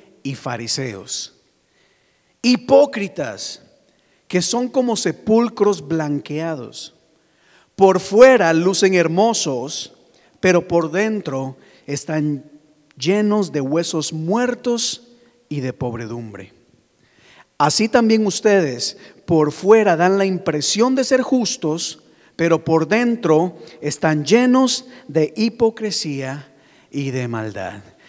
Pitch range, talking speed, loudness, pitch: 150-220 Hz, 95 wpm, -18 LUFS, 165 Hz